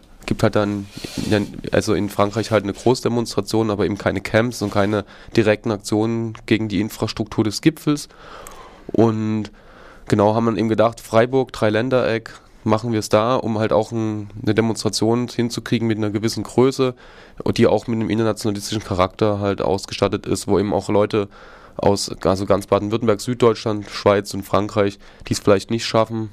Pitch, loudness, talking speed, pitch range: 110 Hz, -20 LUFS, 160 wpm, 105-115 Hz